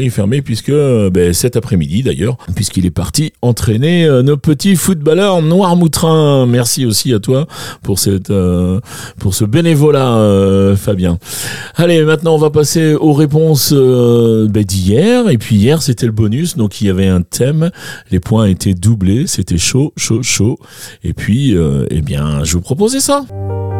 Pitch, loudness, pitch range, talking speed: 120 Hz, -12 LUFS, 100-155 Hz, 170 wpm